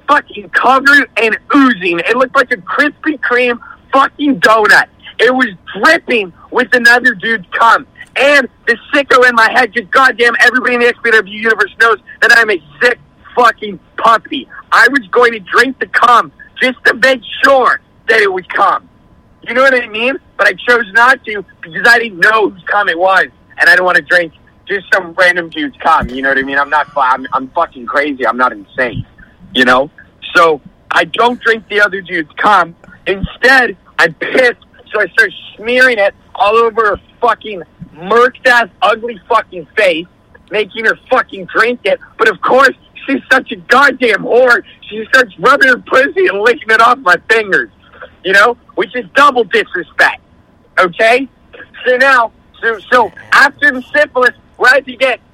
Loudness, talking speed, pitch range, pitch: -10 LUFS, 180 wpm, 200-265 Hz, 240 Hz